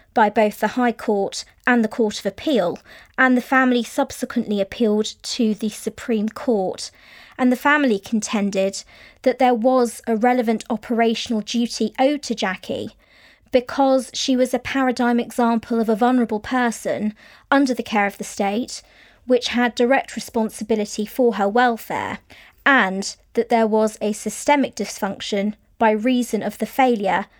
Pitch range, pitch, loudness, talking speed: 215-255 Hz, 230 Hz, -20 LUFS, 150 wpm